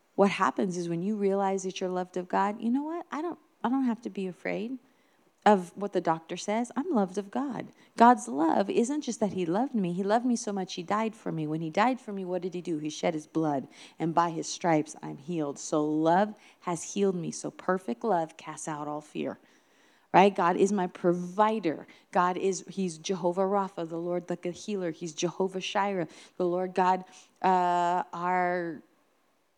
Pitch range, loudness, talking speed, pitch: 175-210 Hz, -29 LUFS, 205 wpm, 185 Hz